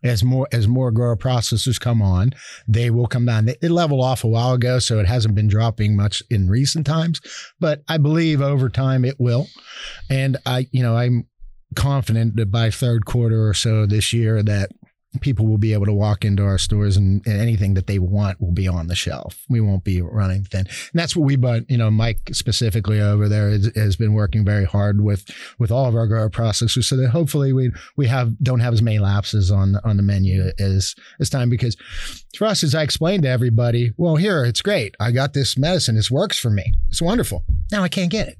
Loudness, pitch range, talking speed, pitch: -19 LUFS, 105-130 Hz, 220 wpm, 115 Hz